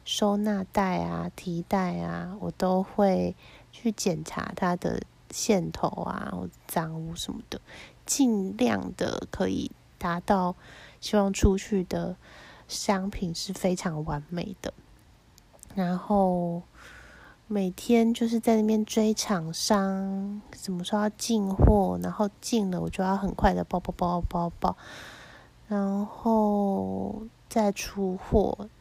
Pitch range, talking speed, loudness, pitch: 175-210 Hz, 170 characters per minute, -28 LUFS, 195 Hz